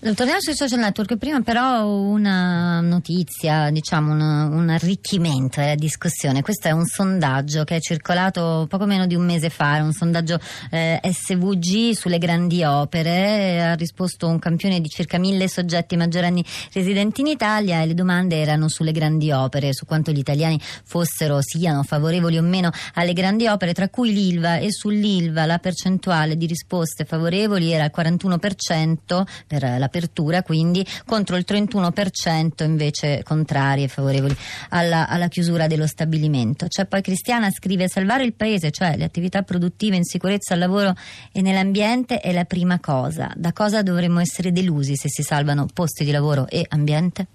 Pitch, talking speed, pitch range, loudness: 175 Hz, 165 wpm, 155-190 Hz, -20 LUFS